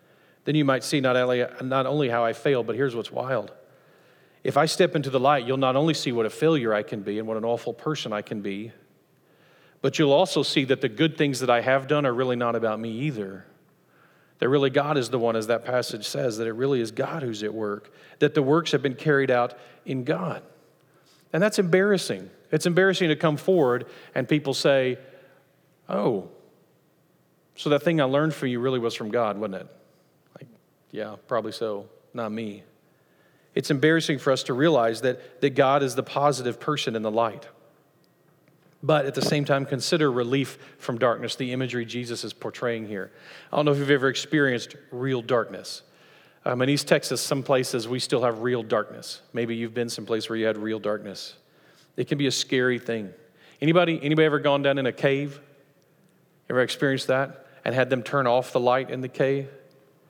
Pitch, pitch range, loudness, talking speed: 135 Hz, 120-150 Hz, -25 LUFS, 200 wpm